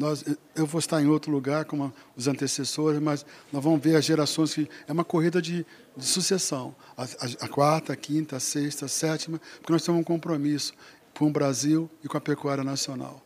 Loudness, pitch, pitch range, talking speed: -27 LUFS, 150 Hz, 140-160 Hz, 210 wpm